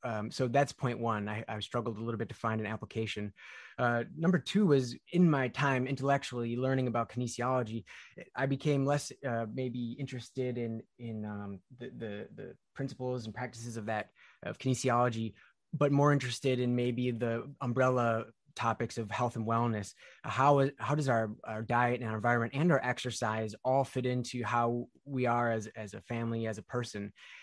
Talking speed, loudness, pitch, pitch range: 180 wpm, -33 LUFS, 120 Hz, 115-130 Hz